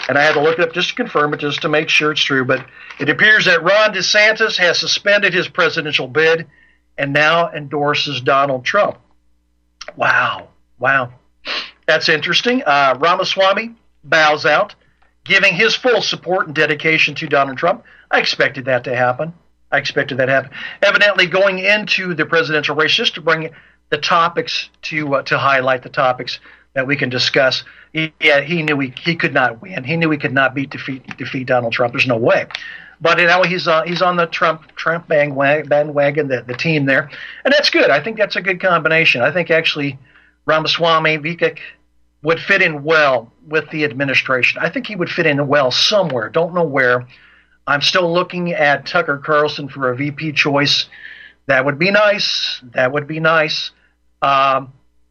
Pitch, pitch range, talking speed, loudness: 155 Hz, 135-170 Hz, 185 wpm, -15 LUFS